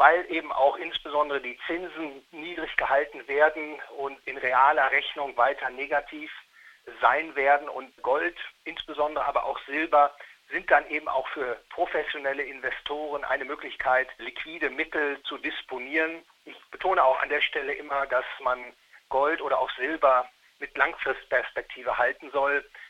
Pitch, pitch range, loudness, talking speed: 150 Hz, 140-160 Hz, -27 LUFS, 140 wpm